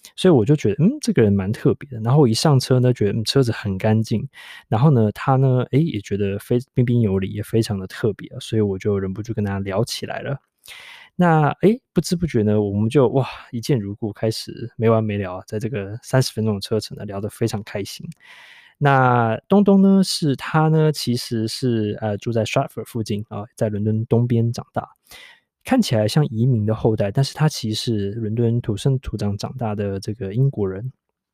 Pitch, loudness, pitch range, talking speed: 115 Hz, -20 LUFS, 105-140 Hz, 310 characters per minute